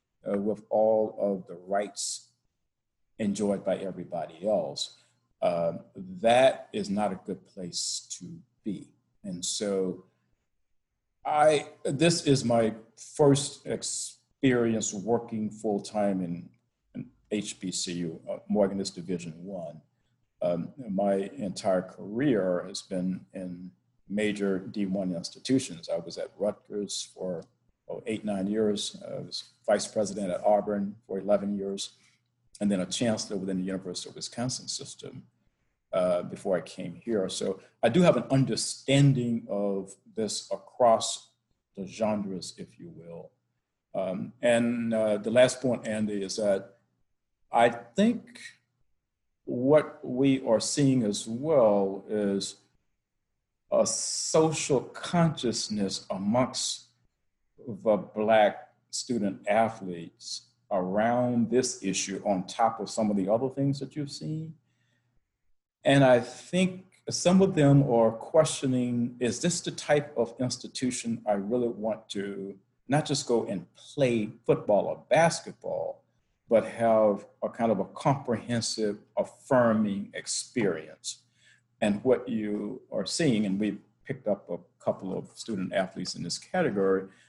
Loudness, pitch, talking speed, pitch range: -28 LUFS, 110 Hz, 130 wpm, 100-125 Hz